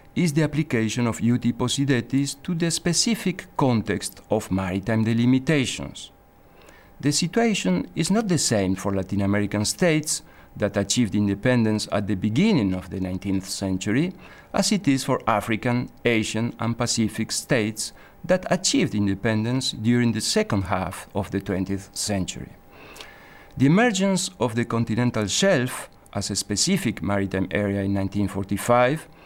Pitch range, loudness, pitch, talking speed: 100-145 Hz, -23 LUFS, 115 Hz, 135 wpm